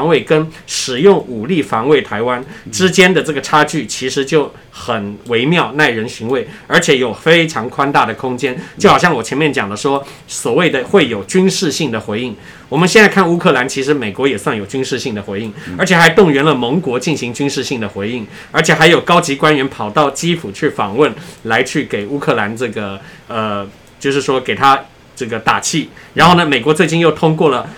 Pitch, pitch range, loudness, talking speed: 140 Hz, 125-160 Hz, -13 LUFS, 300 characters per minute